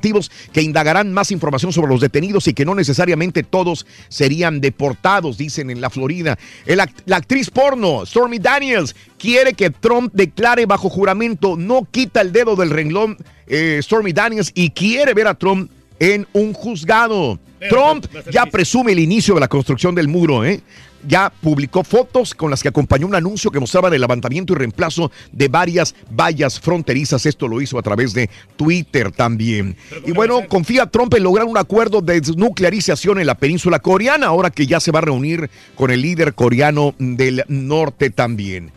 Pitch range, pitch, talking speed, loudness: 140-205 Hz, 175 Hz, 175 wpm, -15 LUFS